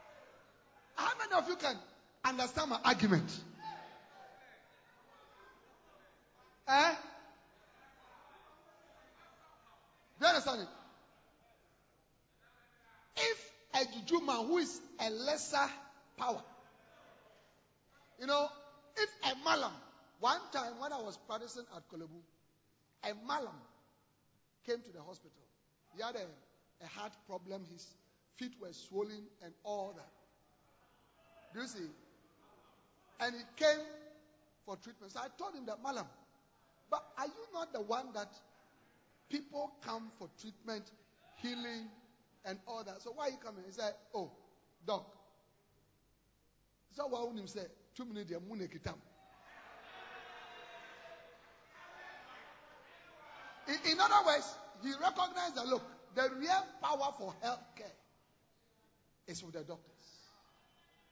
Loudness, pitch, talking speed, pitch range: -38 LUFS, 240 Hz, 115 wpm, 200-285 Hz